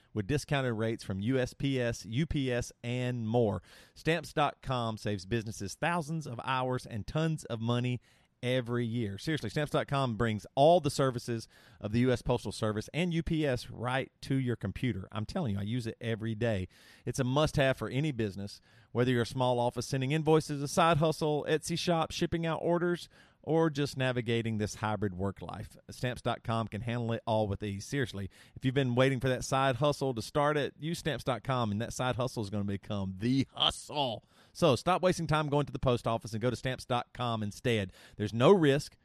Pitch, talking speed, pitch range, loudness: 125 Hz, 185 wpm, 110-145 Hz, -32 LUFS